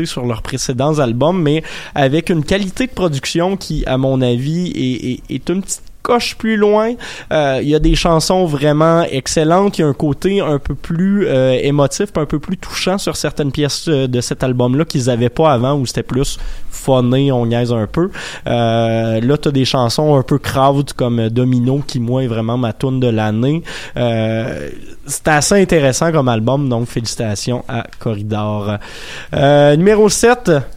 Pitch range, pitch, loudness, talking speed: 125-165 Hz, 140 Hz, -15 LUFS, 180 wpm